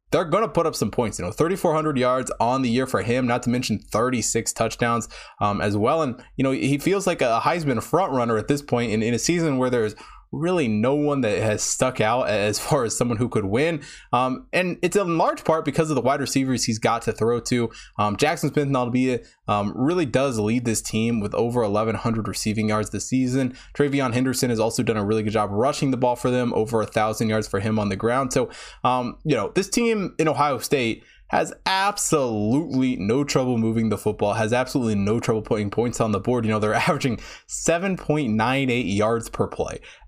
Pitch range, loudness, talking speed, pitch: 110-145 Hz, -23 LUFS, 225 wpm, 125 Hz